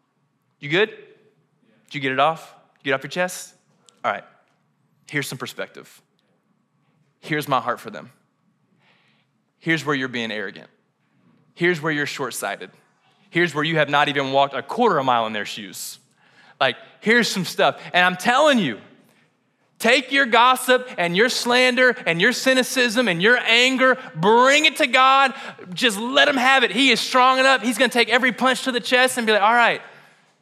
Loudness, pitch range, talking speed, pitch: -18 LUFS, 160-255 Hz, 185 wpm, 230 Hz